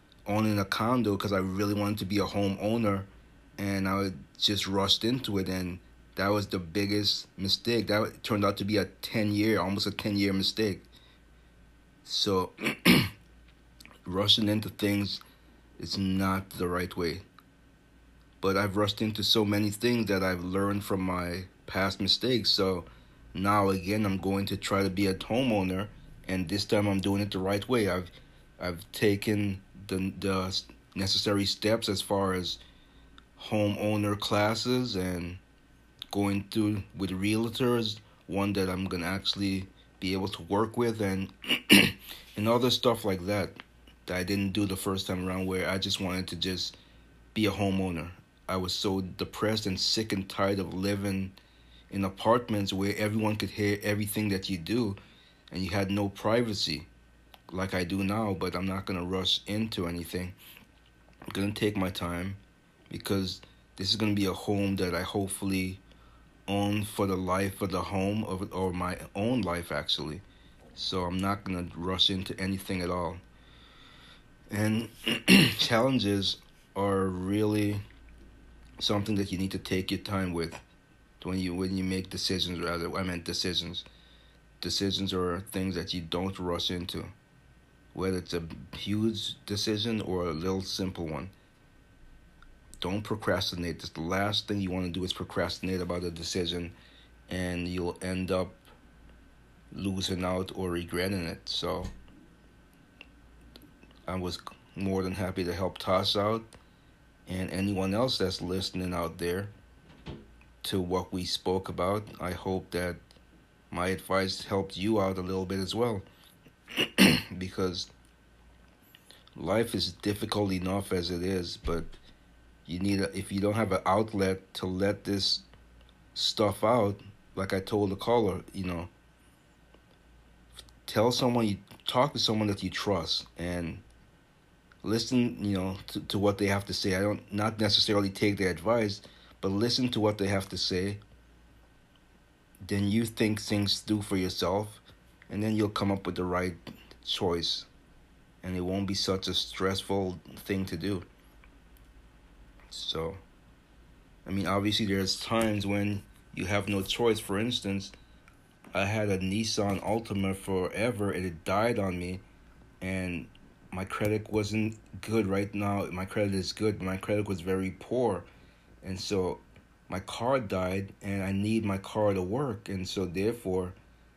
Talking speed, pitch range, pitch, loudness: 155 wpm, 90-105 Hz, 95 Hz, -30 LUFS